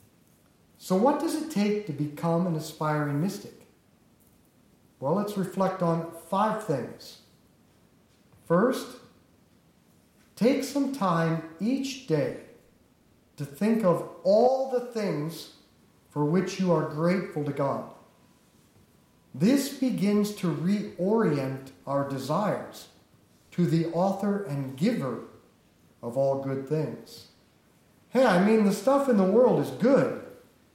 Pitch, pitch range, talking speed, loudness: 185 Hz, 155-225 Hz, 115 wpm, -27 LUFS